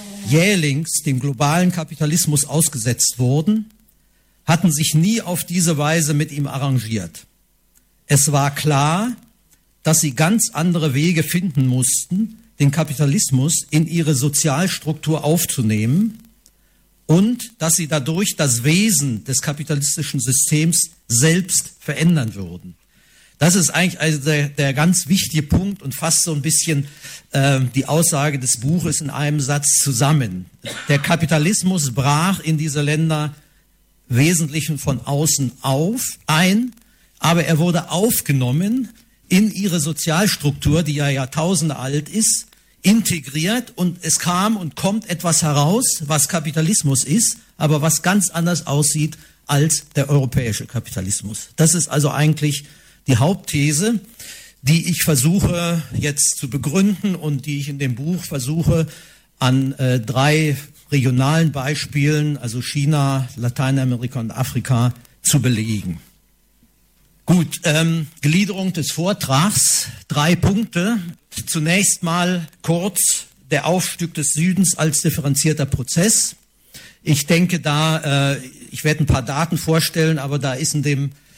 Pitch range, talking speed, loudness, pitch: 140-175 Hz, 125 wpm, -18 LUFS, 155 Hz